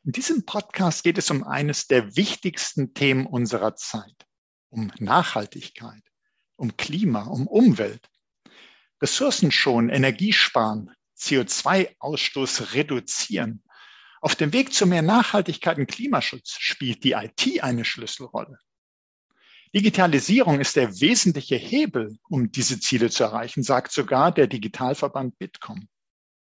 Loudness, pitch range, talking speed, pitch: -22 LUFS, 125-210 Hz, 115 wpm, 145 Hz